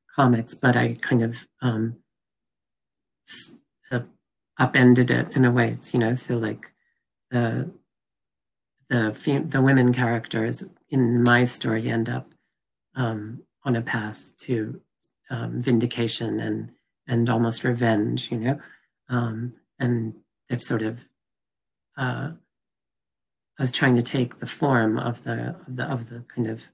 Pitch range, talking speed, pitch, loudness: 115-125 Hz, 135 wpm, 120 Hz, -24 LUFS